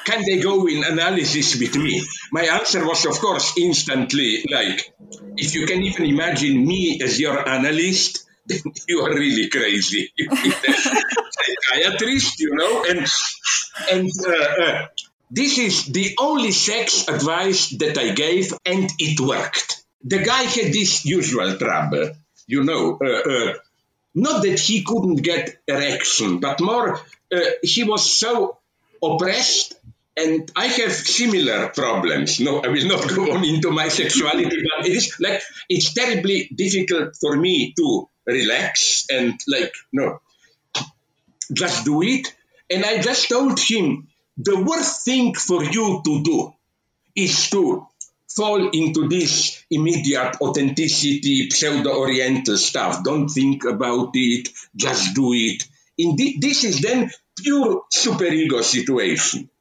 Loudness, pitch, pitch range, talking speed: -19 LUFS, 185 Hz, 155-240 Hz, 140 wpm